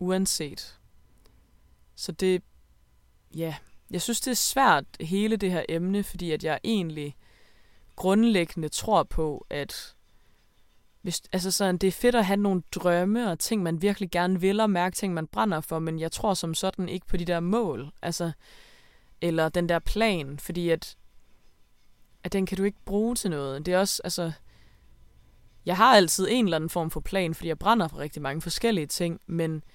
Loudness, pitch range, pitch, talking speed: -26 LUFS, 150-195 Hz, 175 Hz, 180 wpm